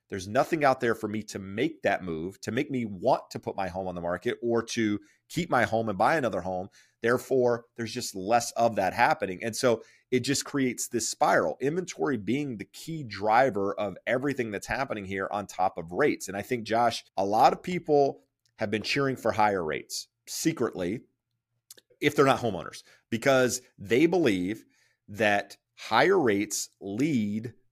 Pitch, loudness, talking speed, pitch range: 115 Hz, -28 LUFS, 180 wpm, 105-130 Hz